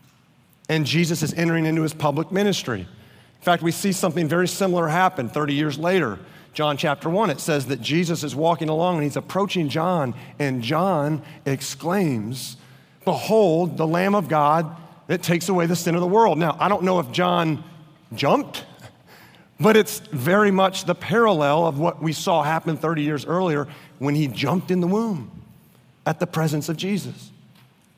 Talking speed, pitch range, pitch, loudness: 175 wpm, 150-180 Hz, 165 Hz, -22 LUFS